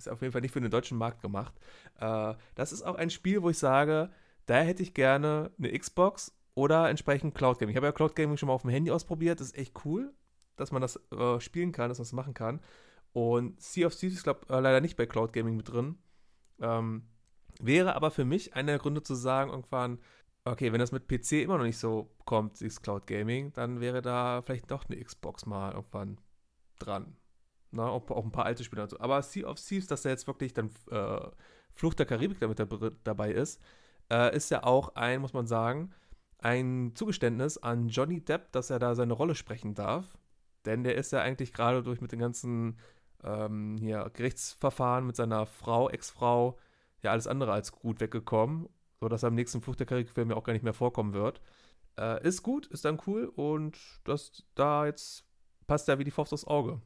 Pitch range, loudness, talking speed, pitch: 115-145 Hz, -32 LUFS, 210 wpm, 125 Hz